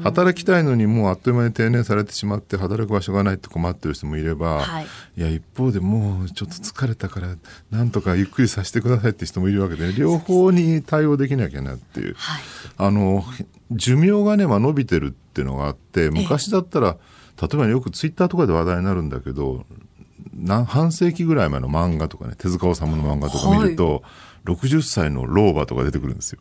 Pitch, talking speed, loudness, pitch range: 100 Hz, 415 characters per minute, -21 LUFS, 85-130 Hz